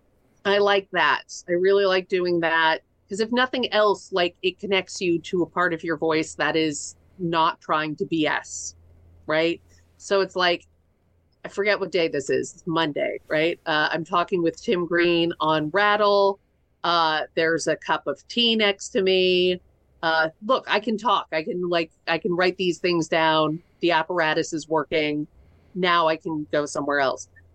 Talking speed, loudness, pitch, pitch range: 180 wpm, -23 LUFS, 170 Hz, 155-185 Hz